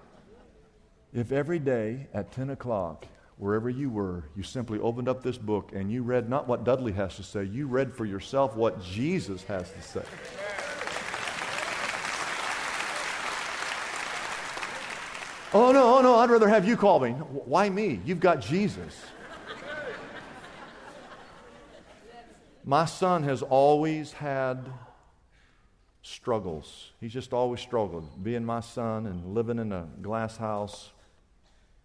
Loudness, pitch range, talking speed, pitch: -28 LUFS, 105-145 Hz, 125 wpm, 125 Hz